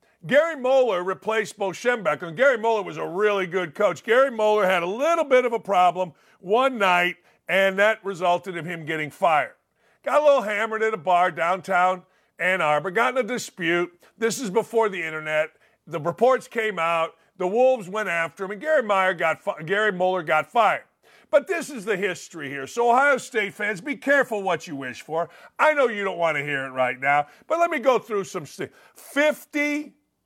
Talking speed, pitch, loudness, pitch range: 200 wpm, 200 Hz, -23 LUFS, 175-245 Hz